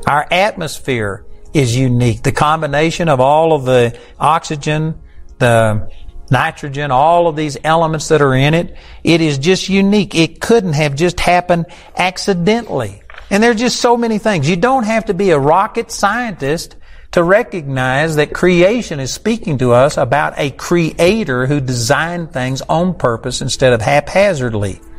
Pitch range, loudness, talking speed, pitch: 130-185 Hz, -14 LUFS, 155 wpm, 160 Hz